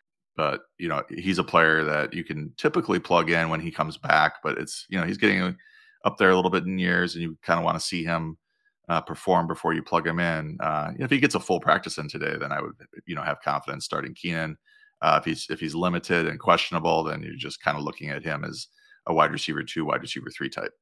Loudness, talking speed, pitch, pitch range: -25 LUFS, 255 wpm, 85 Hz, 80-95 Hz